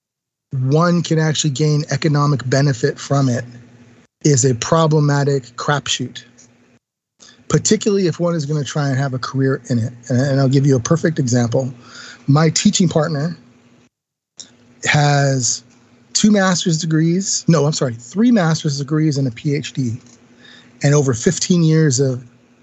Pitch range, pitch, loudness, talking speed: 125-155 Hz, 140 Hz, -16 LUFS, 140 wpm